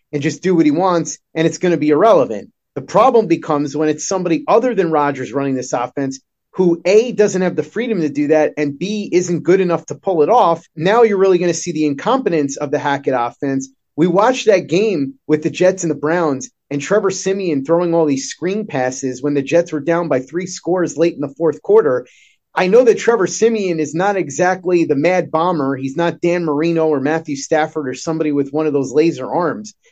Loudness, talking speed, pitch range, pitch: -16 LUFS, 225 wpm, 150-185 Hz, 165 Hz